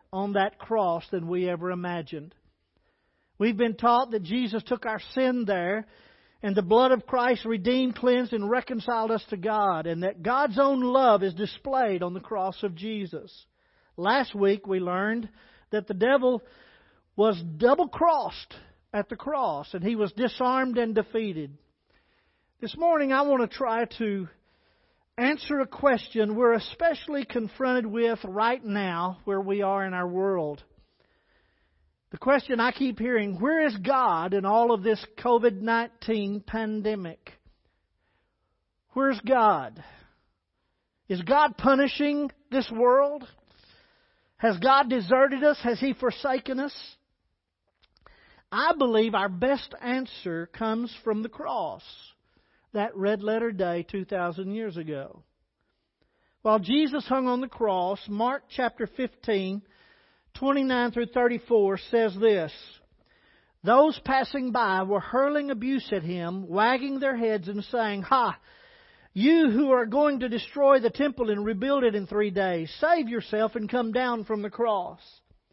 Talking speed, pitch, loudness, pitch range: 140 wpm, 230 Hz, -26 LUFS, 200-260 Hz